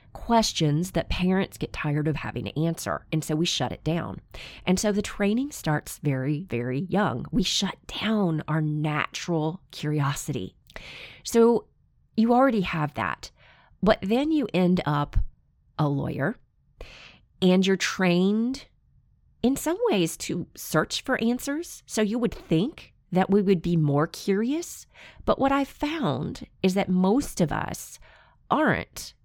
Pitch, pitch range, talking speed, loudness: 185 Hz, 155-225 Hz, 145 wpm, -26 LUFS